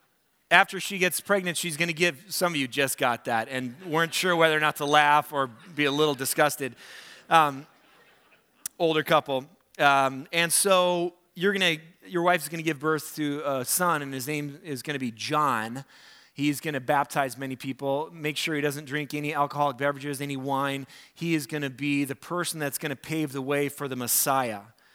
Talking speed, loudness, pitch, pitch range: 205 wpm, -26 LUFS, 150 Hz, 135-165 Hz